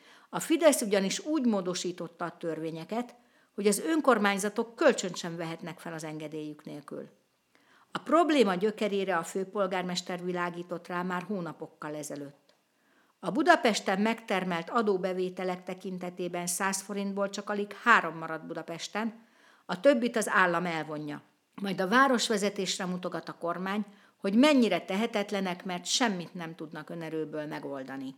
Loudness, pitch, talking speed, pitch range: -30 LUFS, 190 Hz, 125 wpm, 170-215 Hz